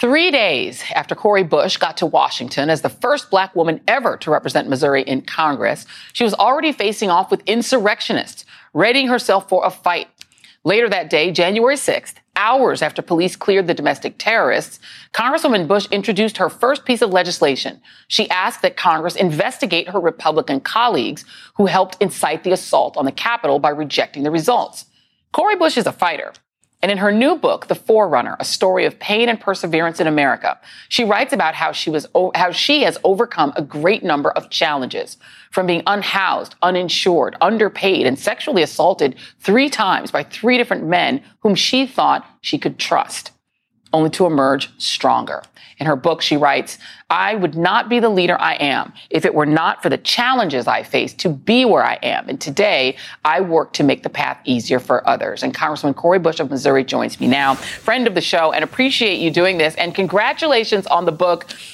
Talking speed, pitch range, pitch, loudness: 185 wpm, 160-225 Hz, 185 Hz, -17 LUFS